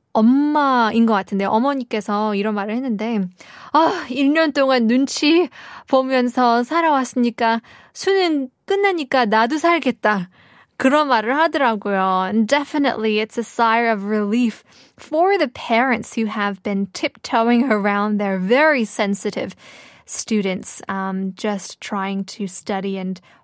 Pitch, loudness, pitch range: 230 Hz, -19 LUFS, 210-275 Hz